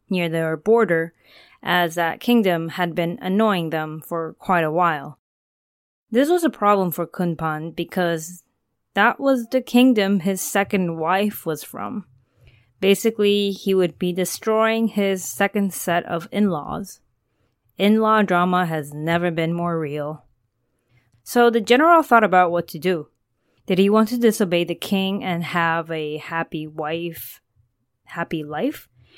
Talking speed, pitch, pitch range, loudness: 140 wpm, 175 Hz, 160-205 Hz, -20 LUFS